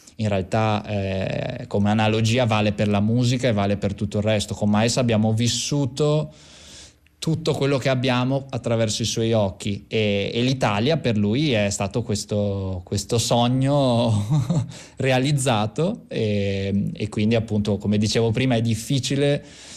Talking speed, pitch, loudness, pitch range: 145 wpm, 115 Hz, -22 LUFS, 105-130 Hz